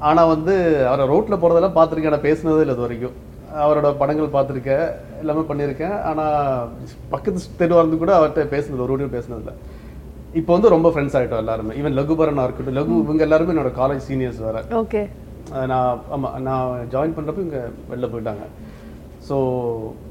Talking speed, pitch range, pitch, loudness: 160 wpm, 125-160 Hz, 145 Hz, -19 LUFS